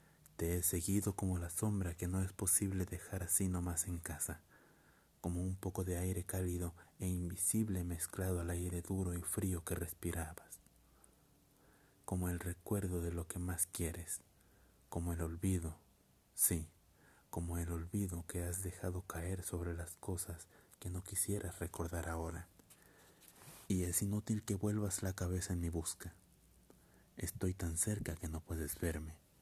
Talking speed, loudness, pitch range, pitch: 155 wpm, -40 LUFS, 85-95 Hz, 90 Hz